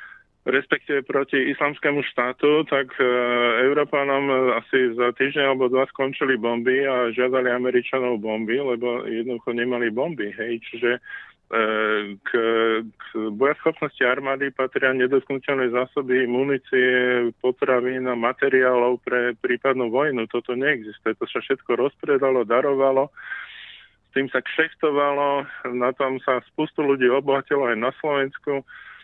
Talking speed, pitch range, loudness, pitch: 120 wpm, 120-135 Hz, -22 LUFS, 130 Hz